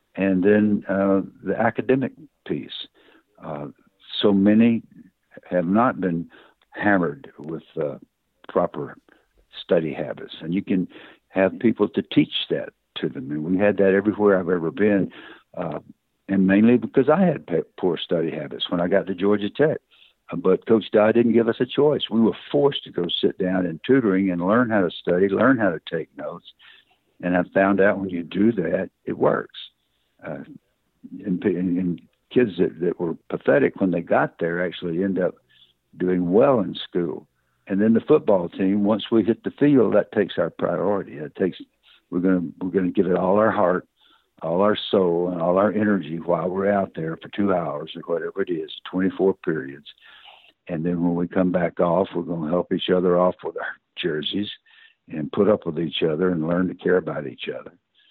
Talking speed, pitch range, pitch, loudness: 190 wpm, 90-110 Hz, 95 Hz, -22 LUFS